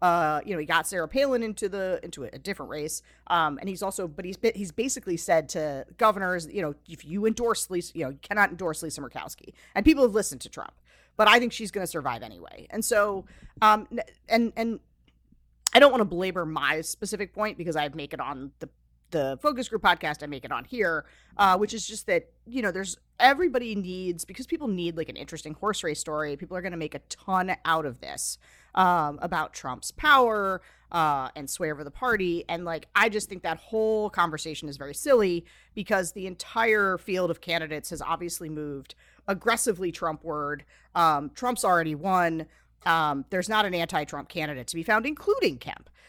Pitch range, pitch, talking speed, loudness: 155-215 Hz, 185 Hz, 205 wpm, -27 LUFS